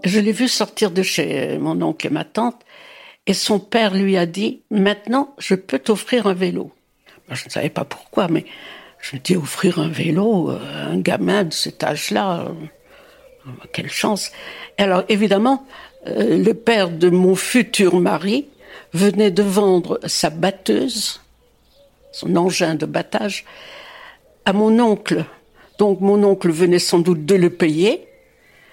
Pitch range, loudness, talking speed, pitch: 180-230 Hz, -18 LUFS, 150 wpm, 200 Hz